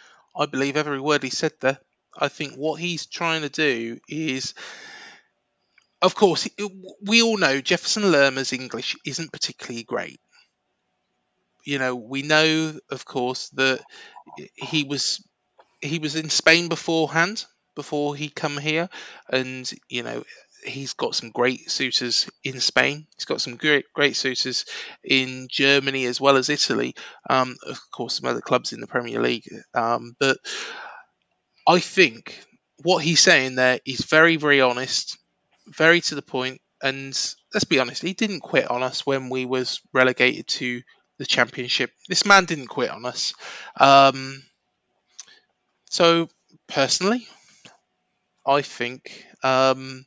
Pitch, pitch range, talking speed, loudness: 140 Hz, 130-165 Hz, 145 wpm, -21 LUFS